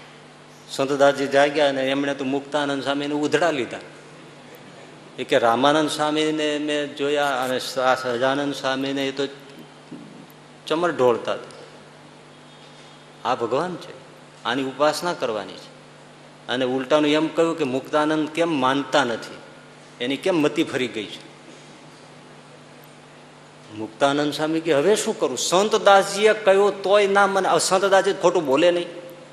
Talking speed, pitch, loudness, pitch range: 115 wpm, 145 Hz, -21 LUFS, 135-165 Hz